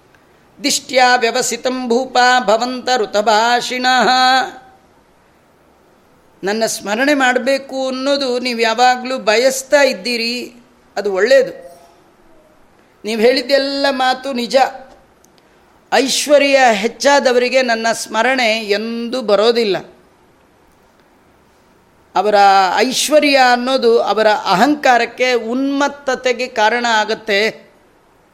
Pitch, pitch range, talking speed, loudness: 250 Hz, 225-265 Hz, 70 wpm, -14 LUFS